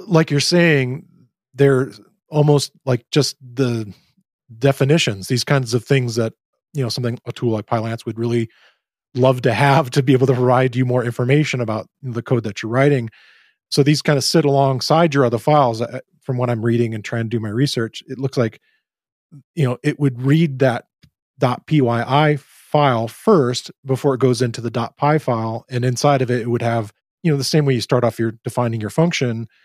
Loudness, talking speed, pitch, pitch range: -18 LUFS, 200 wpm, 130 Hz, 120-145 Hz